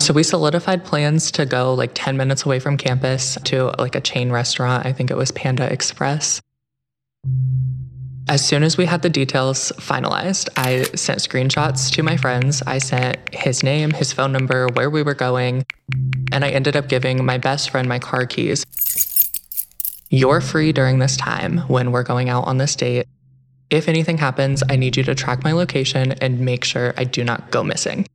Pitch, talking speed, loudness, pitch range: 130 Hz, 190 wpm, -18 LUFS, 130-145 Hz